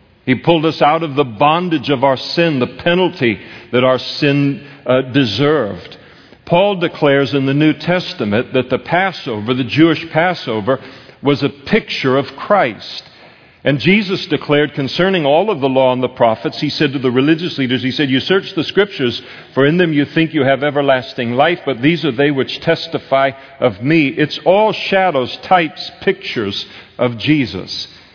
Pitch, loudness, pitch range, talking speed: 140 Hz, -15 LUFS, 130-165 Hz, 175 wpm